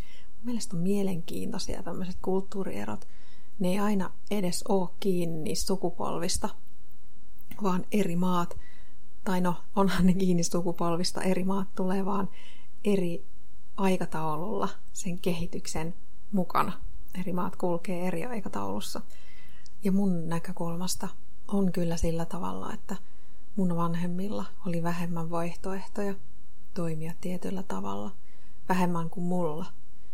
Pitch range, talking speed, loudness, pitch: 170-190 Hz, 110 wpm, -31 LUFS, 180 Hz